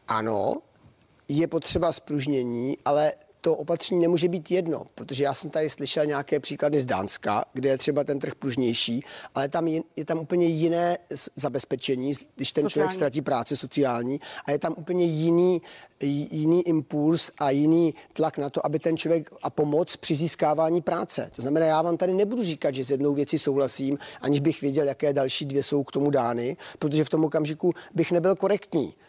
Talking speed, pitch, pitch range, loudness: 180 wpm, 150 Hz, 140-165 Hz, -26 LUFS